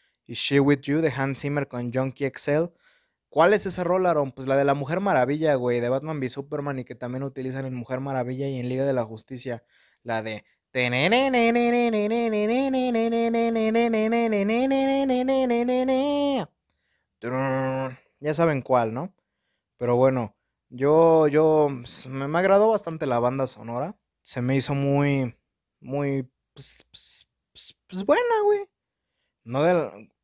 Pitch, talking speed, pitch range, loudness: 140 Hz, 140 wpm, 130-215 Hz, -24 LUFS